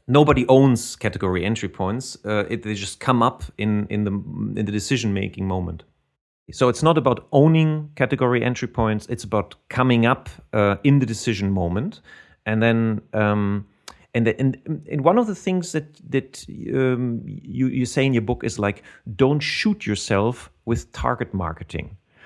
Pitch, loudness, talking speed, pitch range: 115 Hz, -22 LUFS, 170 wpm, 100-135 Hz